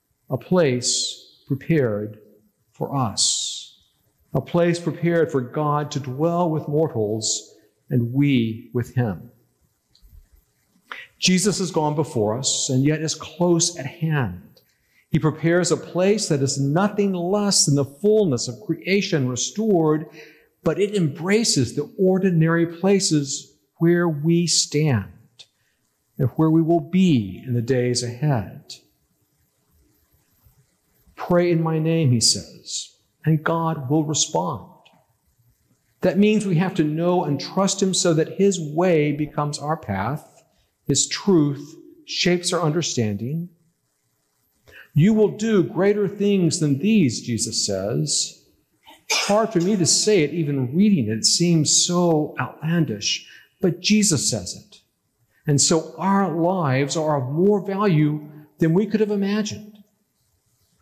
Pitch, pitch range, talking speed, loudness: 155 Hz, 130-175 Hz, 130 wpm, -21 LUFS